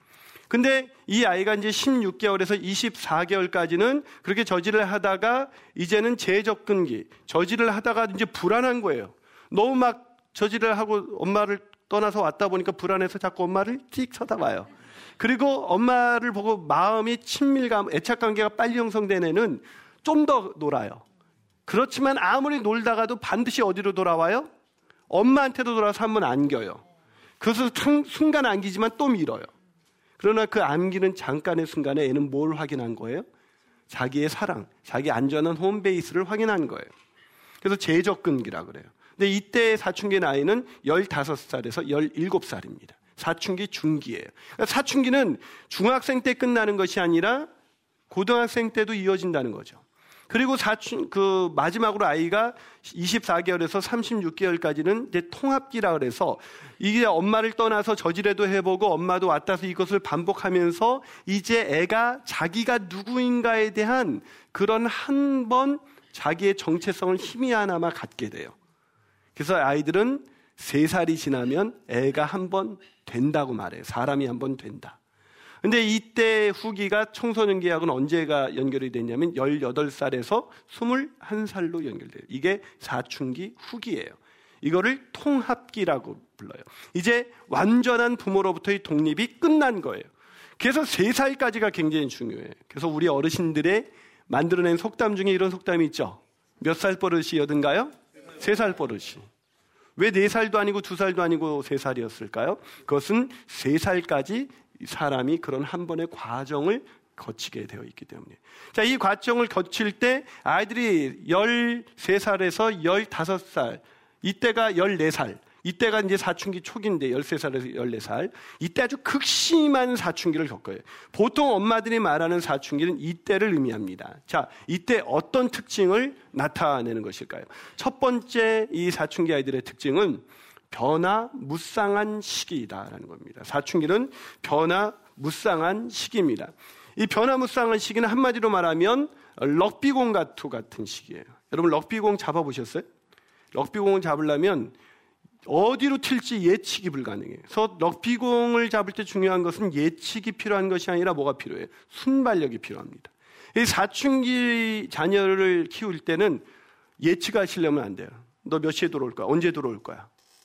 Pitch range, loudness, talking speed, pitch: 170-235 Hz, -25 LUFS, 310 characters per minute, 200 Hz